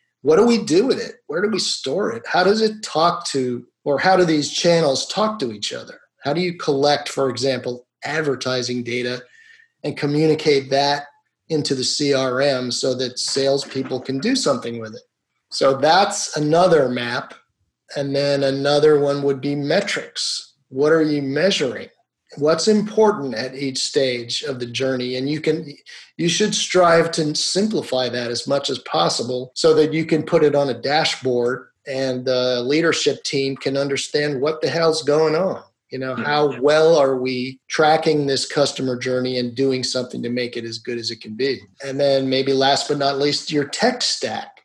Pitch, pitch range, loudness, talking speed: 140 Hz, 130-160 Hz, -19 LUFS, 180 wpm